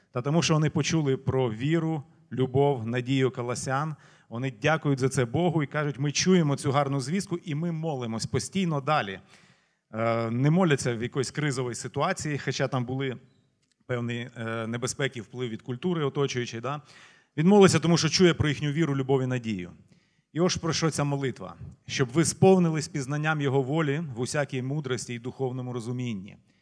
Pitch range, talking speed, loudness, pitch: 125-155 Hz, 160 wpm, -27 LUFS, 140 Hz